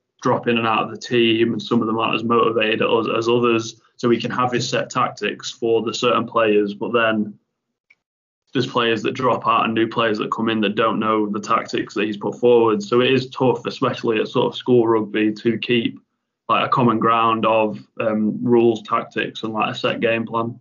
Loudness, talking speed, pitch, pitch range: -19 LUFS, 220 wpm, 115 Hz, 110-120 Hz